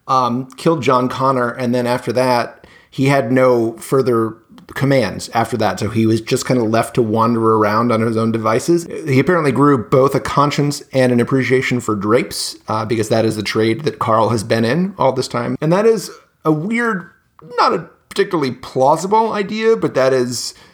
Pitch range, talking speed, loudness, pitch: 115-145 Hz, 195 wpm, -16 LUFS, 130 Hz